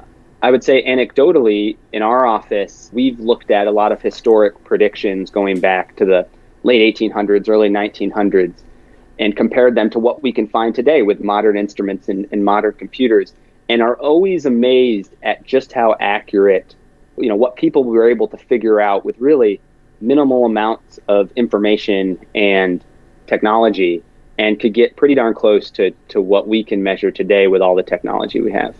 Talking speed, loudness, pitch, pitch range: 175 wpm, -15 LUFS, 110 Hz, 100-125 Hz